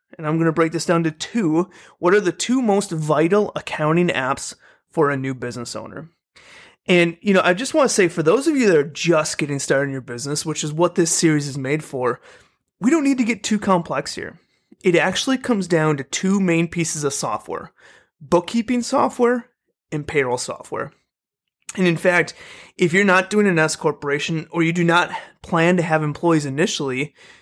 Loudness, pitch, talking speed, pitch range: -19 LUFS, 170 Hz, 200 wpm, 155-190 Hz